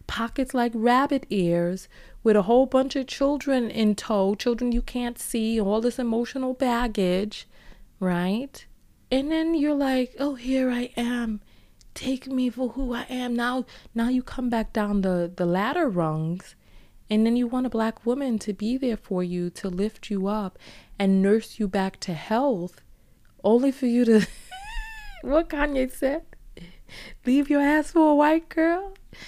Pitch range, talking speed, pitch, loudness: 210-270 Hz, 165 wpm, 240 Hz, -25 LUFS